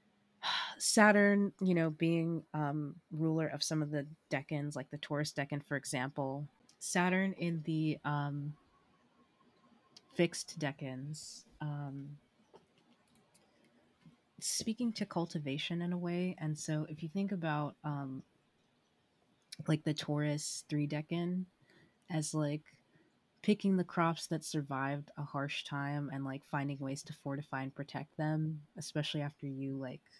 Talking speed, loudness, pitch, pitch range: 130 wpm, -37 LUFS, 150 Hz, 145-170 Hz